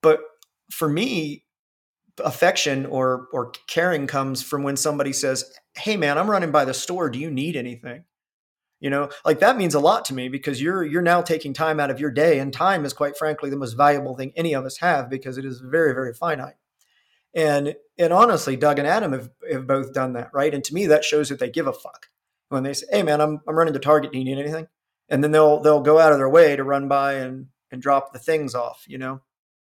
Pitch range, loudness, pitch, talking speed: 135-155 Hz, -21 LUFS, 145 Hz, 235 wpm